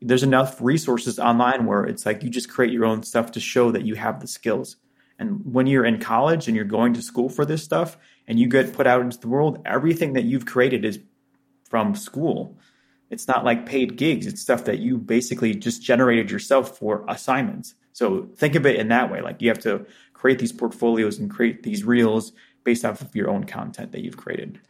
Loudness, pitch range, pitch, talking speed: -22 LUFS, 115-135 Hz, 125 Hz, 220 wpm